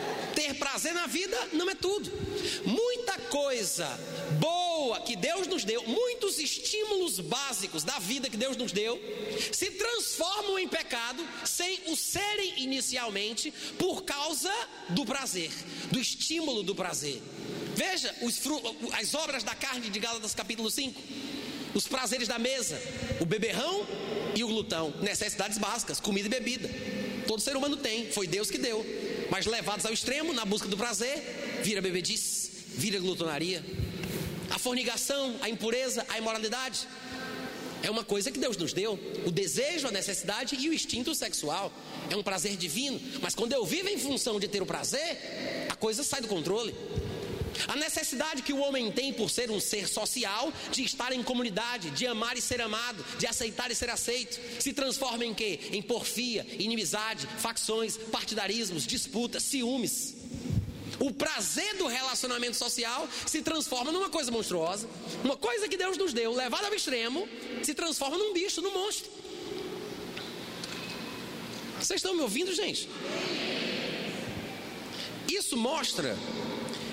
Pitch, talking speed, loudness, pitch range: 250 Hz, 150 wpm, -31 LUFS, 220-305 Hz